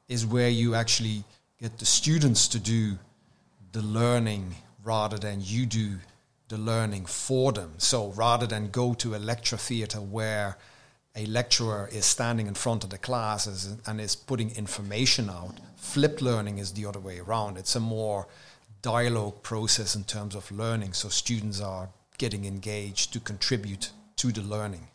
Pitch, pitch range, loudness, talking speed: 110 Hz, 105-120 Hz, -28 LUFS, 165 wpm